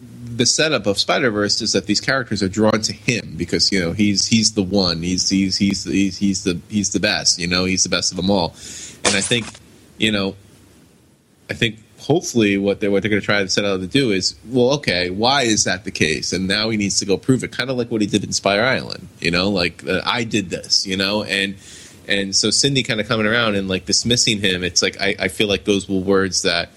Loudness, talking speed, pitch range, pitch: -18 LUFS, 255 wpm, 95-110 Hz, 100 Hz